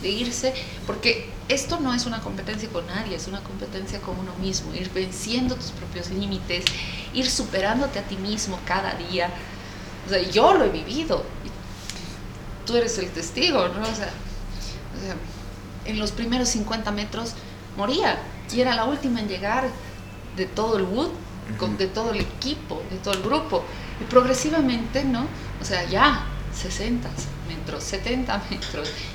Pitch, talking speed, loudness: 200 Hz, 160 wpm, -25 LUFS